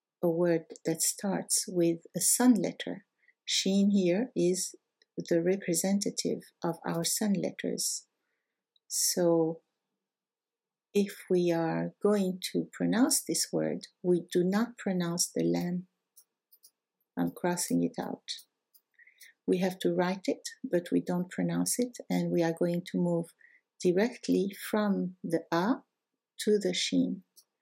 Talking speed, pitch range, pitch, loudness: 130 wpm, 165-205 Hz, 180 Hz, -30 LUFS